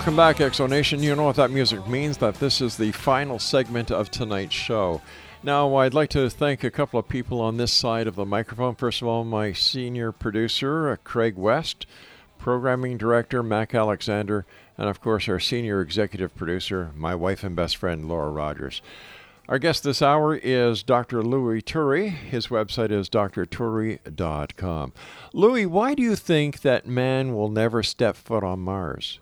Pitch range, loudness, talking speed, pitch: 105-135 Hz, -24 LUFS, 175 wpm, 115 Hz